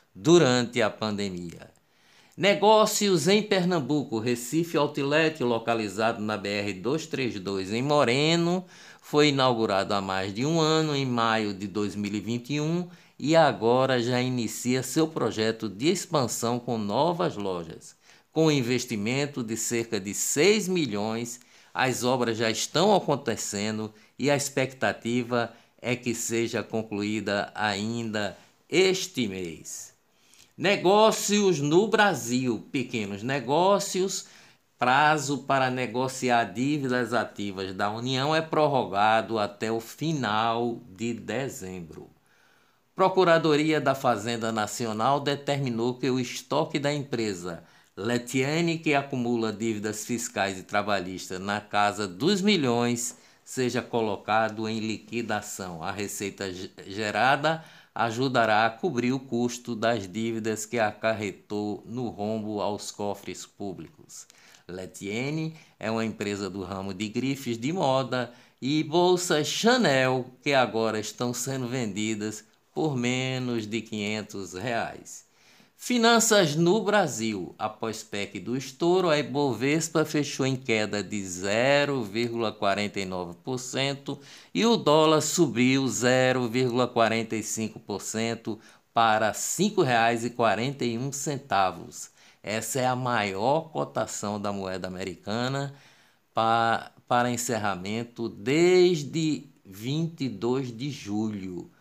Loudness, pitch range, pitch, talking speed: -26 LUFS, 110-145 Hz, 120 Hz, 105 wpm